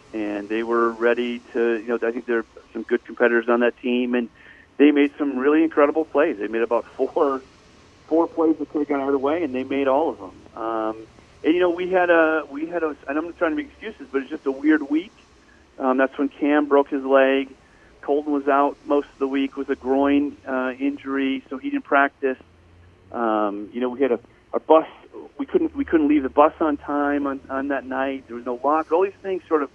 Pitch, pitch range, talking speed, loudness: 135 Hz, 120-150 Hz, 240 wpm, -22 LUFS